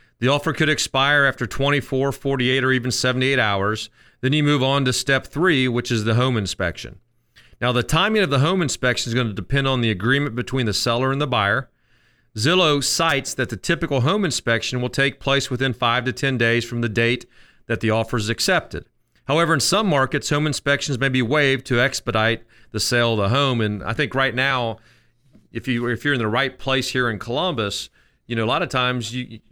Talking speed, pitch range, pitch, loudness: 215 wpm, 115-140 Hz, 125 Hz, -20 LUFS